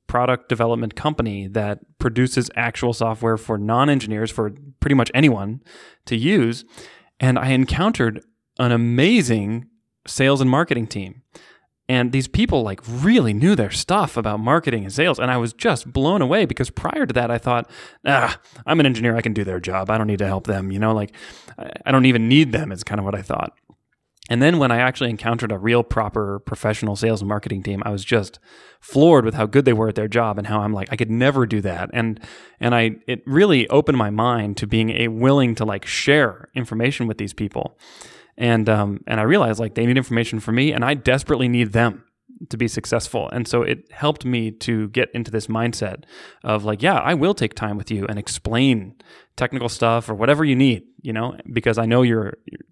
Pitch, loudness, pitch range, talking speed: 115 Hz, -20 LUFS, 110-130 Hz, 210 wpm